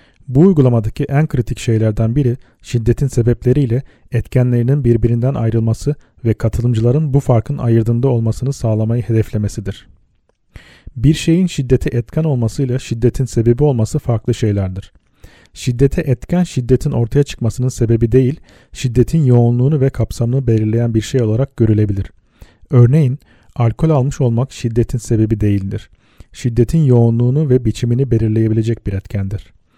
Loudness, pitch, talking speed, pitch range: -15 LUFS, 120 Hz, 120 wpm, 110-135 Hz